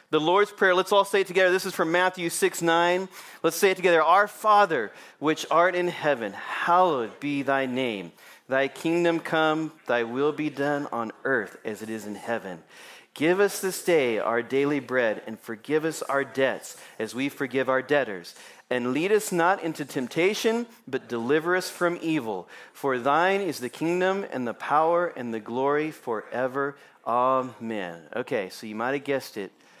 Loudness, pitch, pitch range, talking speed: -25 LUFS, 150 Hz, 130-180 Hz, 180 wpm